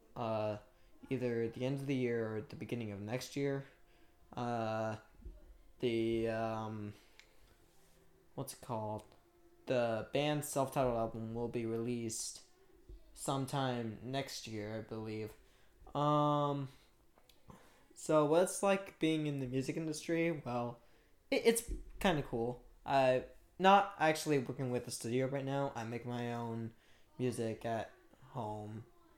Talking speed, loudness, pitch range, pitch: 130 wpm, -37 LUFS, 115-145 Hz, 125 Hz